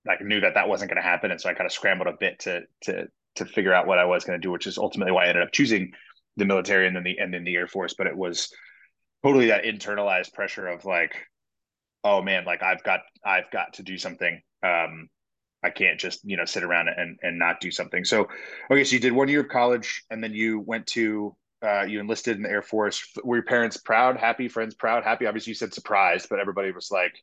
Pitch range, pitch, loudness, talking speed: 95-120 Hz, 110 Hz, -24 LUFS, 250 wpm